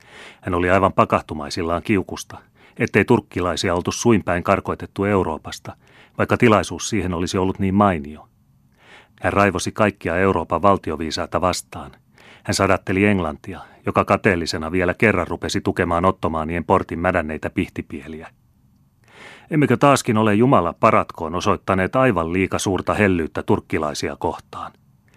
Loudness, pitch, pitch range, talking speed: -20 LUFS, 95 Hz, 85-105 Hz, 115 wpm